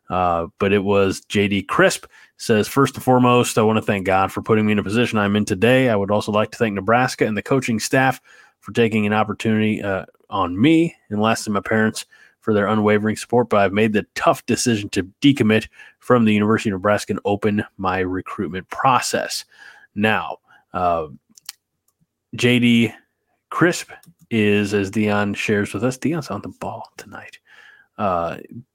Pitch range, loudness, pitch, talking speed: 100-115 Hz, -19 LUFS, 110 Hz, 175 wpm